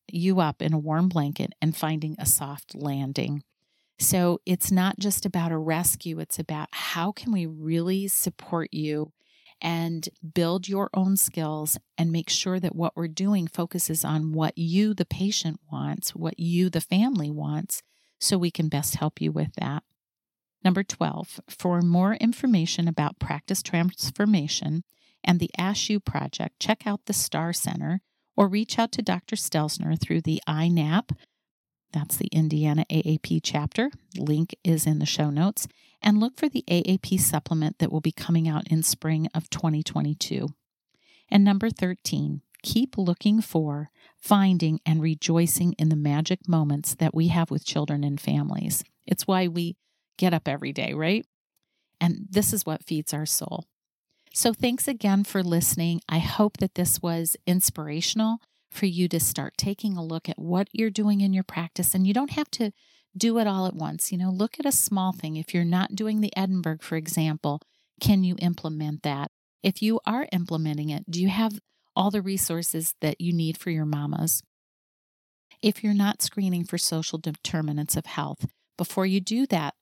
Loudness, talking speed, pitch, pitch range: -26 LUFS, 170 wpm, 170 Hz, 155-195 Hz